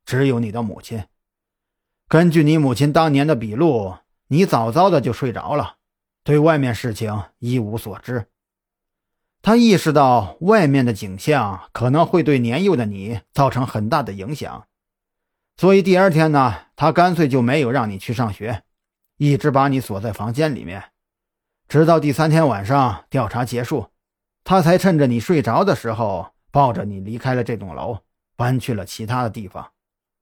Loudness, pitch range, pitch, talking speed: -18 LUFS, 105-150 Hz, 125 Hz, 240 characters per minute